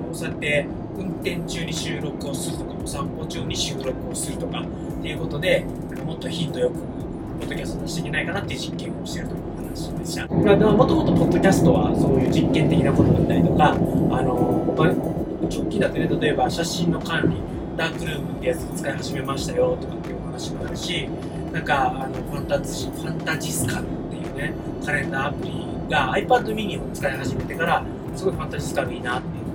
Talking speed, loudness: 440 characters per minute, -23 LUFS